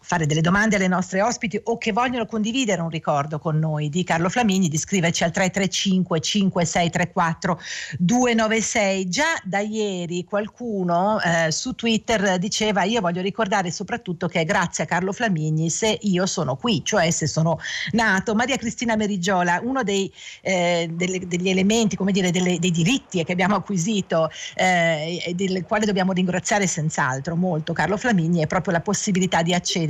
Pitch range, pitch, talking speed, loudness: 170-210 Hz, 185 Hz, 165 wpm, -21 LUFS